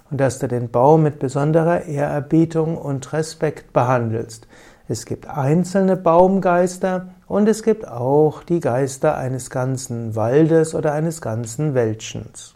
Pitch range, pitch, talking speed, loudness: 130-165 Hz, 150 Hz, 135 wpm, -19 LUFS